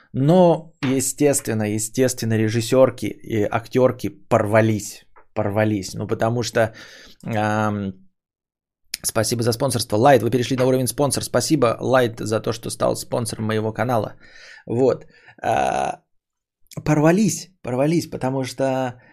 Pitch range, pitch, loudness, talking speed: 110-130 Hz, 120 Hz, -20 LUFS, 115 wpm